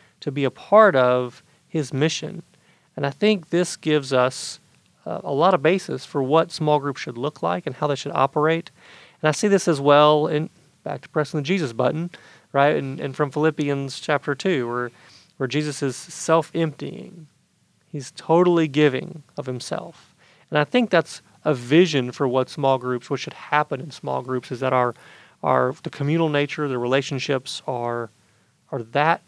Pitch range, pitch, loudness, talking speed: 135-160 Hz, 150 Hz, -22 LUFS, 180 wpm